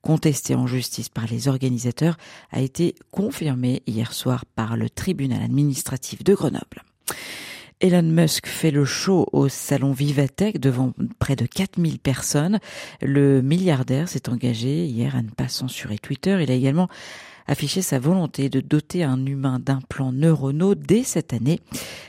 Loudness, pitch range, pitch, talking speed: -22 LUFS, 130-165 Hz, 140 Hz, 150 wpm